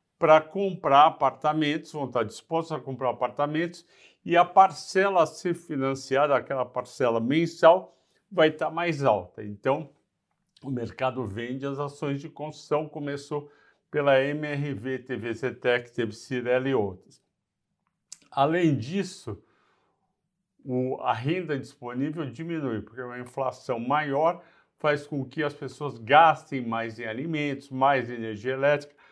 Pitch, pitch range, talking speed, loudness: 145 Hz, 130-160 Hz, 125 wpm, -26 LUFS